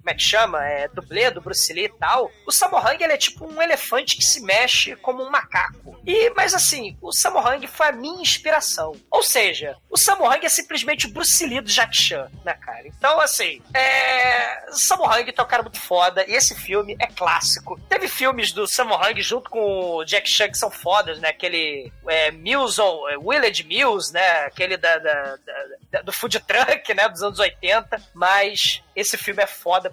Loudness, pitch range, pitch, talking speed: -19 LUFS, 185-295 Hz, 225 Hz, 200 wpm